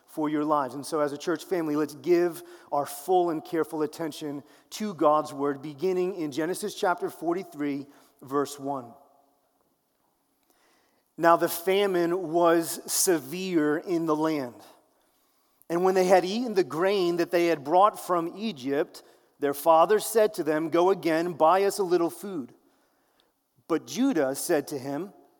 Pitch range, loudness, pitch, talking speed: 150-185 Hz, -26 LUFS, 170 Hz, 150 wpm